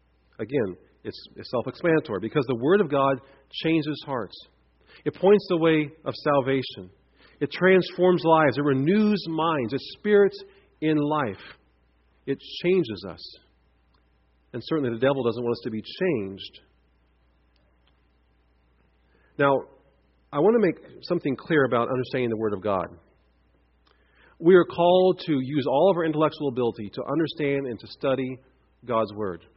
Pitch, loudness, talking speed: 130 Hz, -24 LUFS, 140 wpm